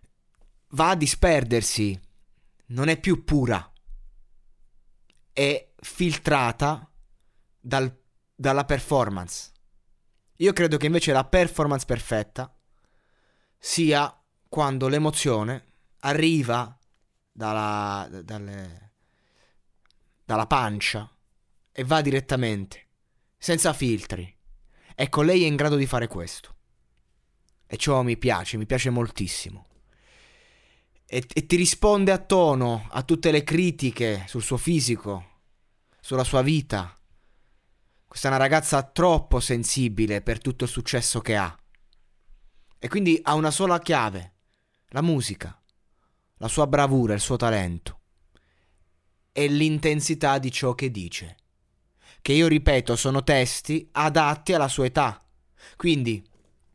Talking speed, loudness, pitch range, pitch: 110 wpm, -24 LUFS, 100-150 Hz, 125 Hz